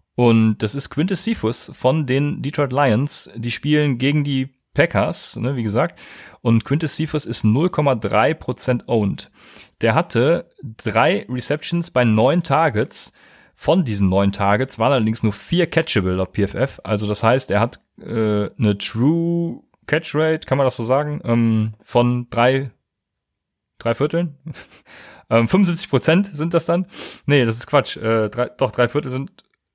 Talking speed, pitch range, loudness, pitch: 155 wpm, 110-150 Hz, -19 LUFS, 130 Hz